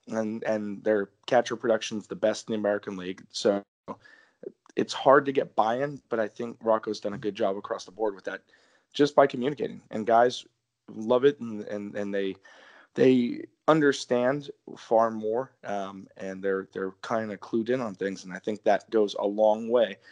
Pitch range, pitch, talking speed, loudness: 100-120 Hz, 110 Hz, 190 wpm, -27 LUFS